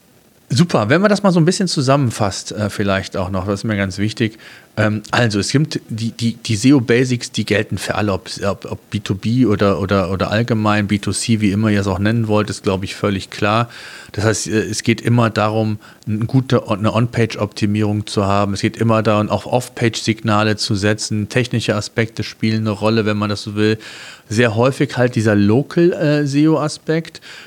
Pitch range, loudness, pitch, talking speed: 105-120 Hz, -17 LUFS, 110 Hz, 180 wpm